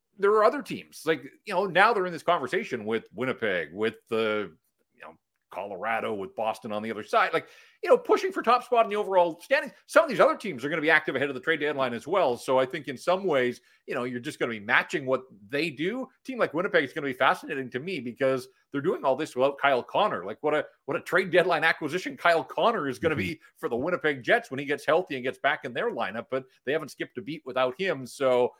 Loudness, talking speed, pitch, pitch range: -27 LUFS, 265 wpm, 150 Hz, 125-185 Hz